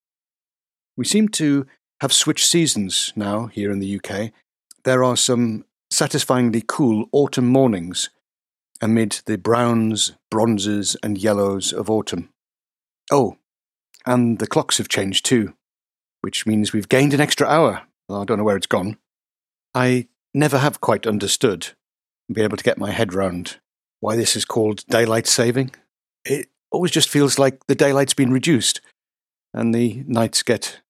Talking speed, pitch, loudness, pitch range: 155 wpm, 115 Hz, -19 LUFS, 105-130 Hz